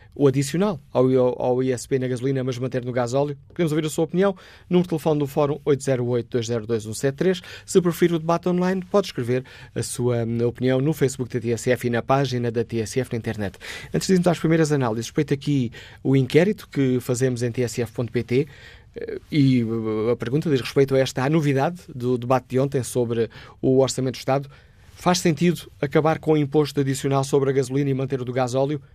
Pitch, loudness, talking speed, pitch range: 135 Hz, -23 LUFS, 190 wpm, 125-155 Hz